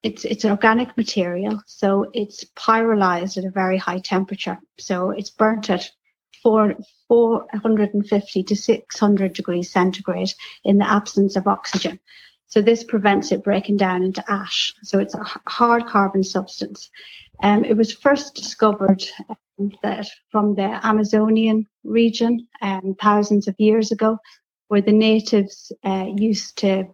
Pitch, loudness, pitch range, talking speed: 205 Hz, -20 LUFS, 195-220 Hz, 145 wpm